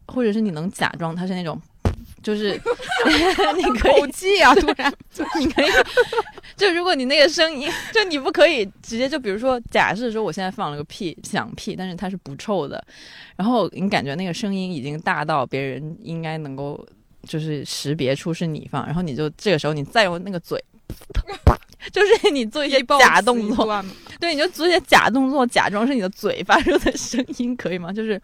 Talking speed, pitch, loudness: 285 characters per minute, 210 Hz, -20 LUFS